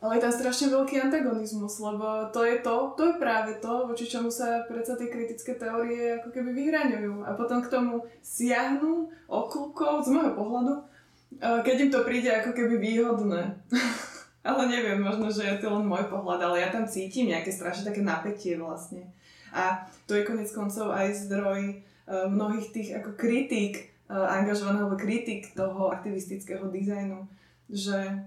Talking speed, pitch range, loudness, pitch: 160 wpm, 200-245 Hz, -29 LUFS, 220 Hz